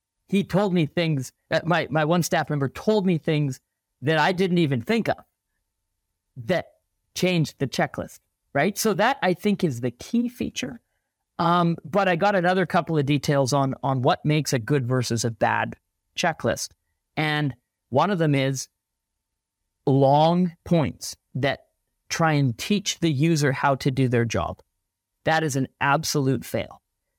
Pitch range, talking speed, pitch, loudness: 135-175 Hz, 160 wpm, 150 Hz, -23 LUFS